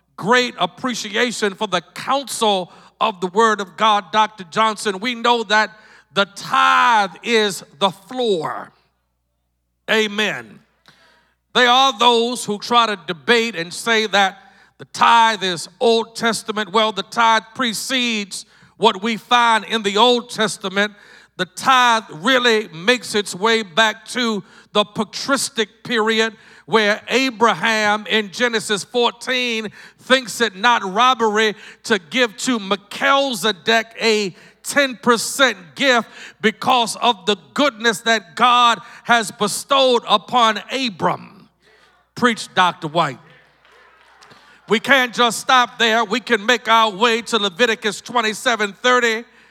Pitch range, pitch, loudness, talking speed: 205-240 Hz, 225 Hz, -17 LUFS, 120 wpm